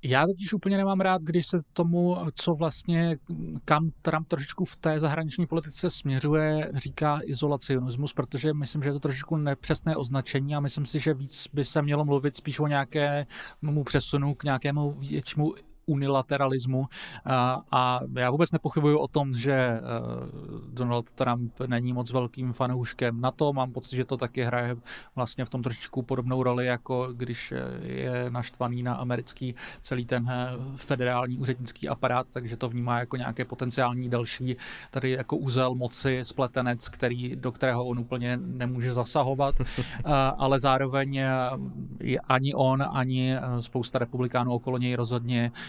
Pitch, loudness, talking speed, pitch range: 130 Hz, -28 LUFS, 150 wpm, 125-145 Hz